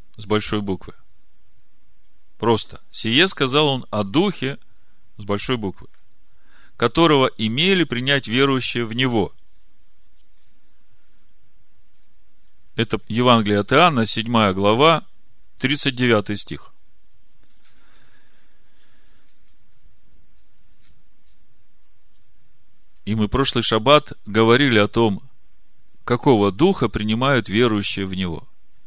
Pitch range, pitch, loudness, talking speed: 100-130 Hz, 110 Hz, -19 LUFS, 80 wpm